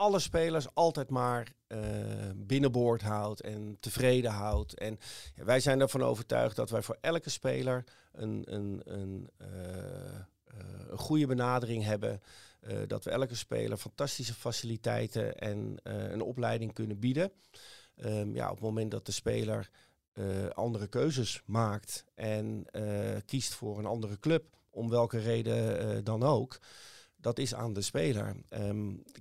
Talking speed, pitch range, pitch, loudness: 150 wpm, 105-125 Hz, 115 Hz, -34 LUFS